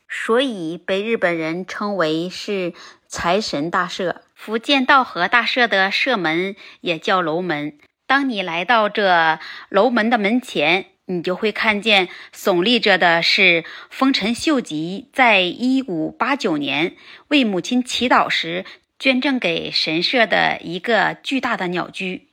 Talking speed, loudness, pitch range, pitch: 190 characters per minute, -18 LUFS, 175-250 Hz, 200 Hz